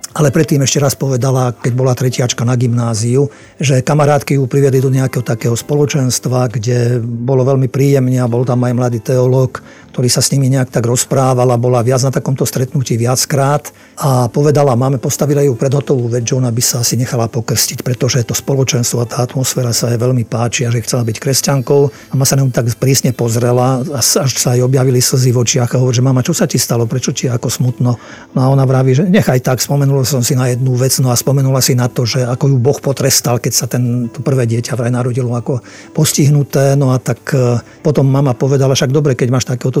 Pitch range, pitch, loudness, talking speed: 125-140 Hz, 130 Hz, -13 LUFS, 215 wpm